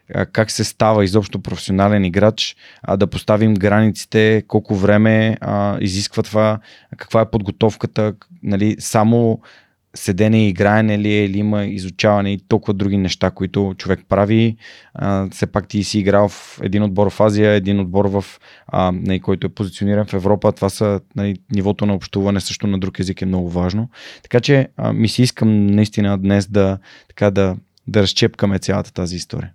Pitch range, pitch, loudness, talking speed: 100-110 Hz, 105 Hz, -17 LUFS, 165 wpm